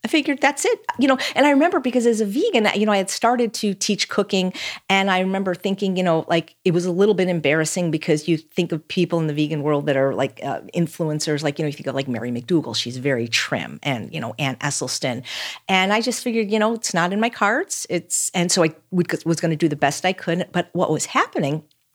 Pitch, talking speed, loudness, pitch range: 175 Hz, 255 wpm, -21 LUFS, 150-210 Hz